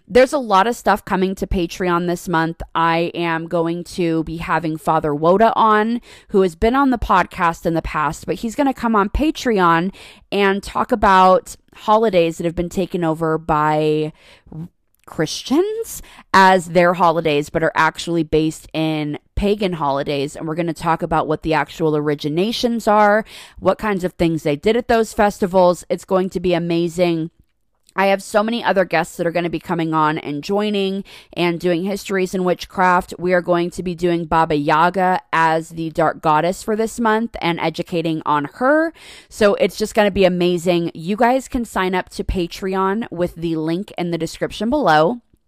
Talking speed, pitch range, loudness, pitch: 185 wpm, 165-200 Hz, -18 LUFS, 175 Hz